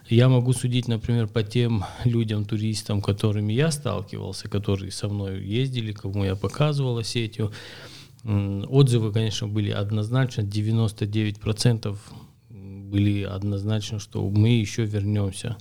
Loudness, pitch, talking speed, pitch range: -25 LUFS, 110 Hz, 115 wpm, 105-120 Hz